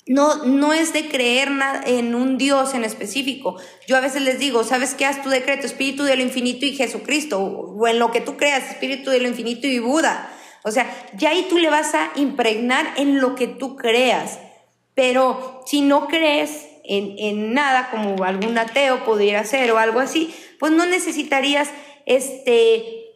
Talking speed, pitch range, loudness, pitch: 185 wpm, 245-285 Hz, -19 LUFS, 265 Hz